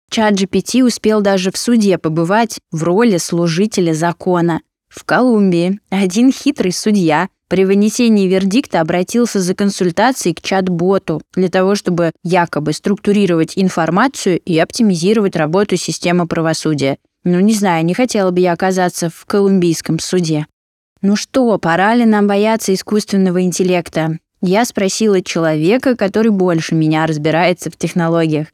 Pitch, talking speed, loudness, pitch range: 185 Hz, 130 wpm, -14 LUFS, 170-205 Hz